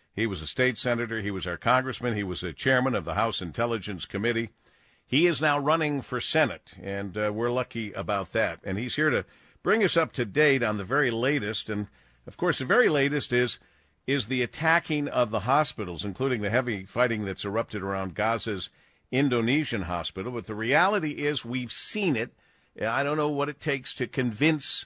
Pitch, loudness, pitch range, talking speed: 120 Hz, -27 LUFS, 100-140 Hz, 195 wpm